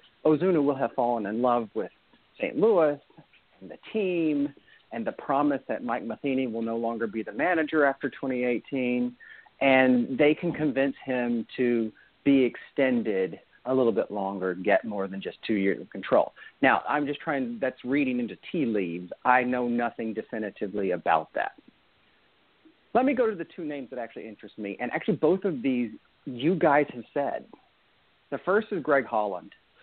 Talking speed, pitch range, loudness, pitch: 175 wpm, 115-145 Hz, -27 LUFS, 125 Hz